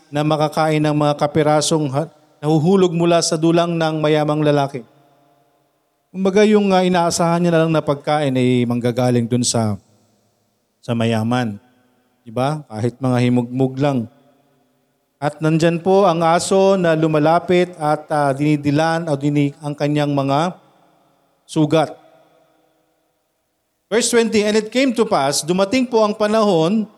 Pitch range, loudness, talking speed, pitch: 140-170 Hz, -17 LUFS, 135 wpm, 150 Hz